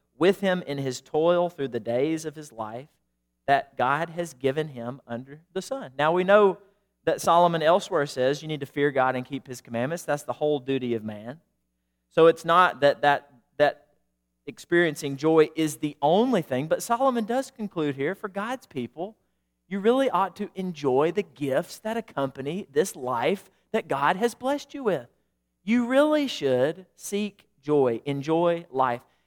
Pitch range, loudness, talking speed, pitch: 130-190 Hz, -25 LUFS, 175 wpm, 155 Hz